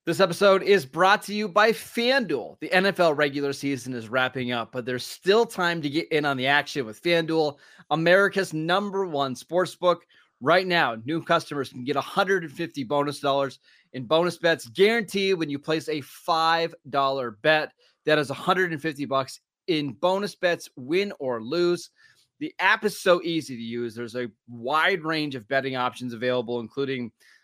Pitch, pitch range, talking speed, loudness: 155 Hz, 135-180 Hz, 165 wpm, -24 LUFS